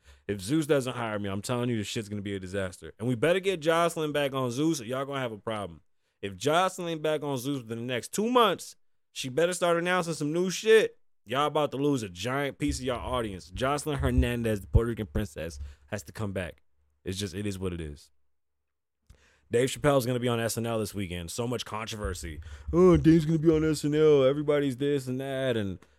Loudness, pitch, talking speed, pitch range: -28 LUFS, 120 Hz, 220 wpm, 100-150 Hz